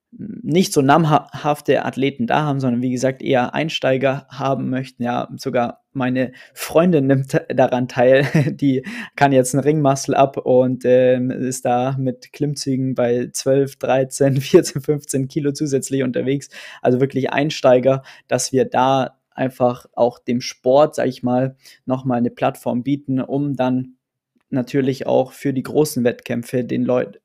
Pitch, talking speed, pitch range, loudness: 130 Hz, 150 wpm, 125-140 Hz, -19 LUFS